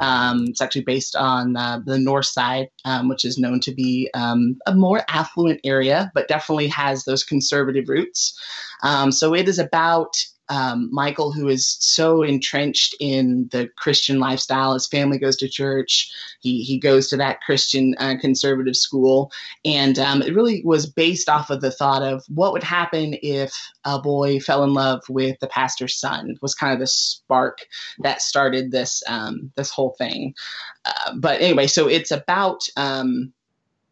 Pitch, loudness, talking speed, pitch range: 135 Hz, -20 LUFS, 175 wpm, 130-145 Hz